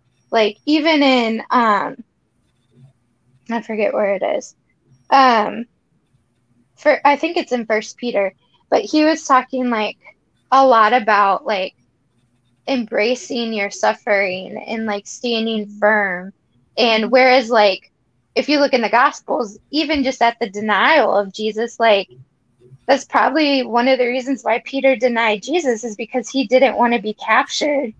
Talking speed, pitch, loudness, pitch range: 145 wpm, 225 Hz, -17 LUFS, 200-255 Hz